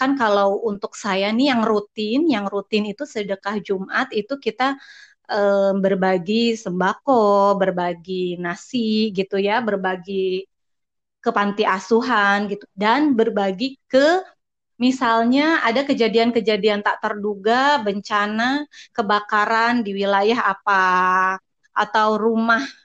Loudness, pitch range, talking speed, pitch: -20 LUFS, 200-235 Hz, 110 wpm, 215 Hz